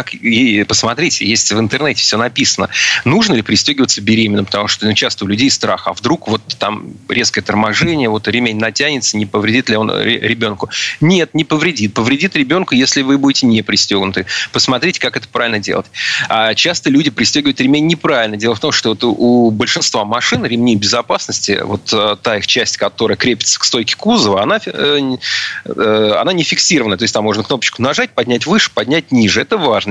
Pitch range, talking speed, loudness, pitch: 110-150 Hz, 175 wpm, -13 LUFS, 120 Hz